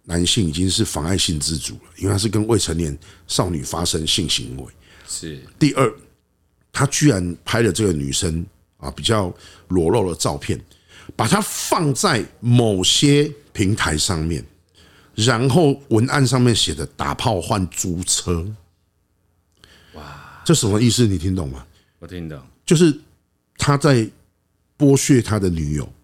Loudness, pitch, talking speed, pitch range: -19 LUFS, 90 Hz, 210 characters per minute, 85-115 Hz